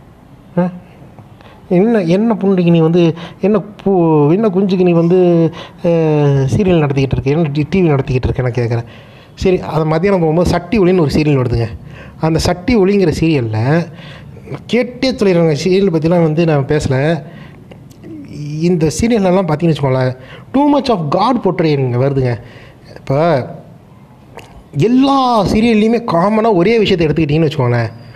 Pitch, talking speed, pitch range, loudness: 165 Hz, 120 wpm, 140-190 Hz, -13 LUFS